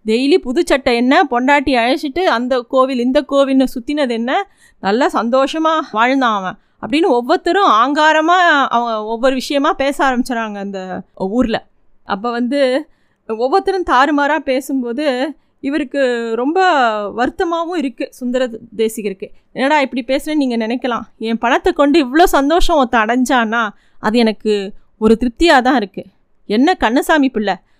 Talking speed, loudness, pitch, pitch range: 125 wpm, -15 LUFS, 265 Hz, 235-300 Hz